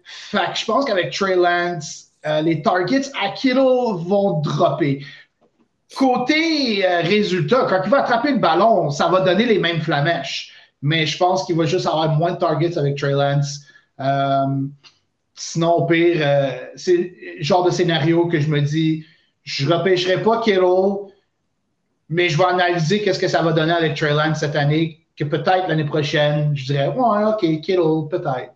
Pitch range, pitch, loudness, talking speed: 155-185 Hz, 170 Hz, -18 LUFS, 180 wpm